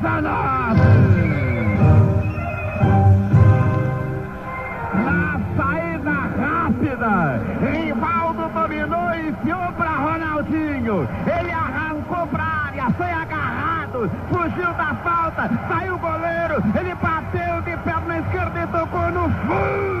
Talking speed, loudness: 95 wpm, -20 LUFS